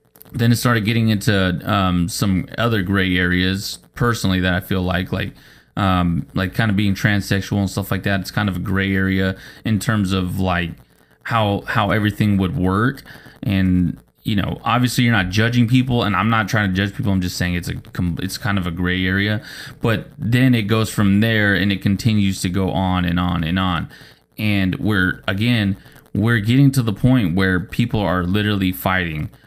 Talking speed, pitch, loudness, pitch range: 195 wpm, 100 Hz, -19 LUFS, 95-110 Hz